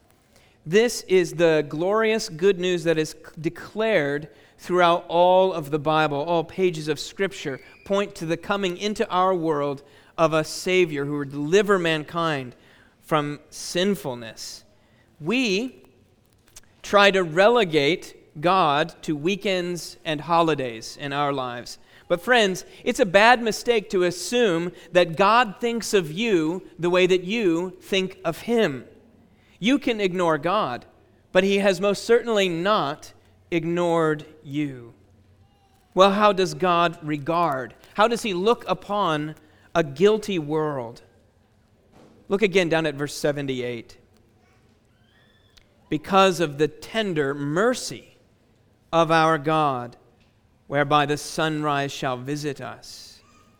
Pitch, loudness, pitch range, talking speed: 165 Hz, -22 LUFS, 140-190 Hz, 125 wpm